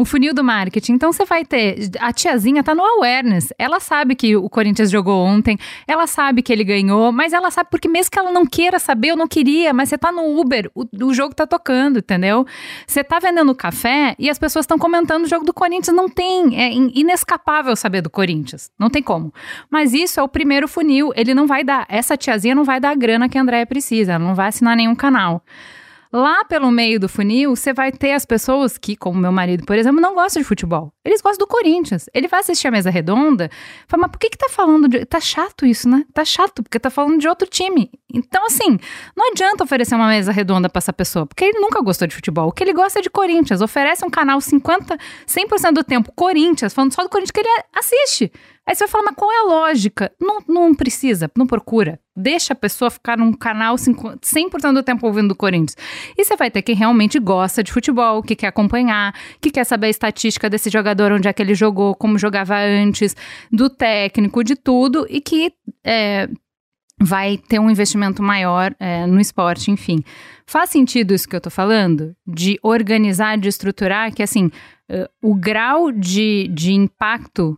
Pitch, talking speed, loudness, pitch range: 250 Hz, 210 wpm, -16 LUFS, 210-315 Hz